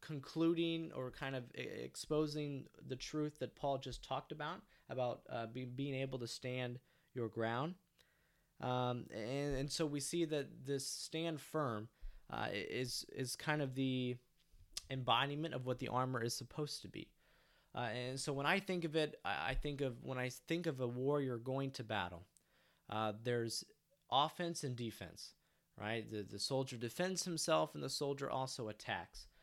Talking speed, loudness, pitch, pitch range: 165 wpm, -42 LUFS, 135 Hz, 125-150 Hz